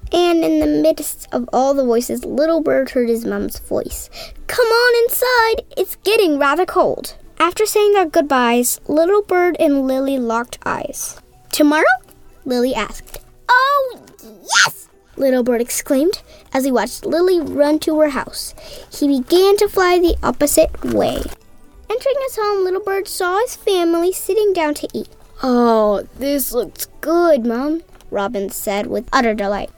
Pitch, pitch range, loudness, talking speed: 315 Hz, 265-385 Hz, -17 LUFS, 155 wpm